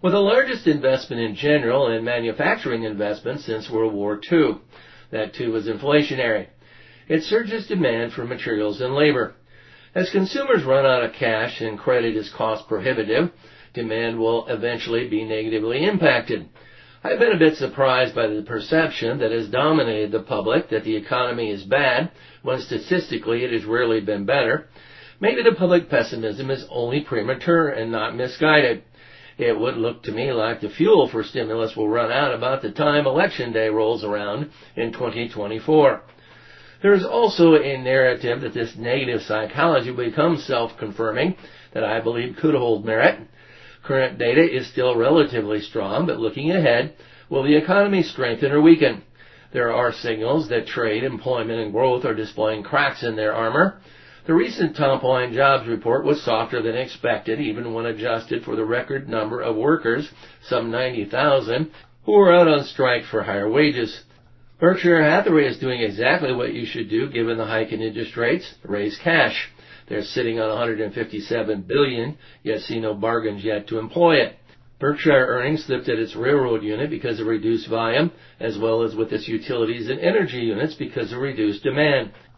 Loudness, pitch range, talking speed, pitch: -21 LUFS, 110-145 Hz, 170 wpm, 120 Hz